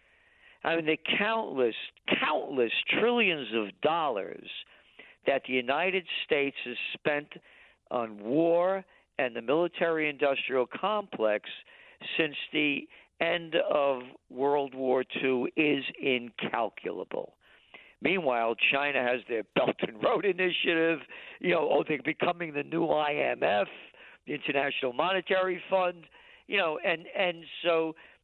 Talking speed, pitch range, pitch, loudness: 115 wpm, 135-185 Hz, 155 Hz, -29 LUFS